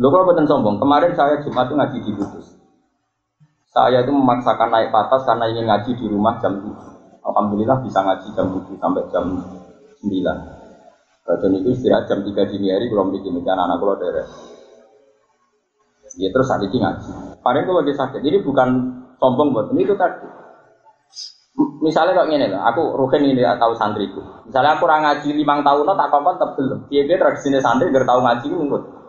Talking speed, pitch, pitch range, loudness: 180 wpm, 130 Hz, 115-150 Hz, -18 LUFS